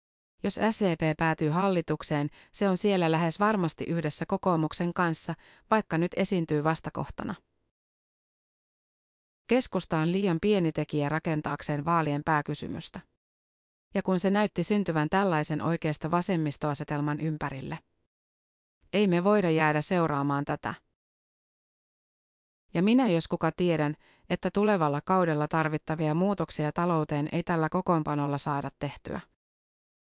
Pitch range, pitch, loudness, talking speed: 150-185 Hz, 160 Hz, -28 LUFS, 110 wpm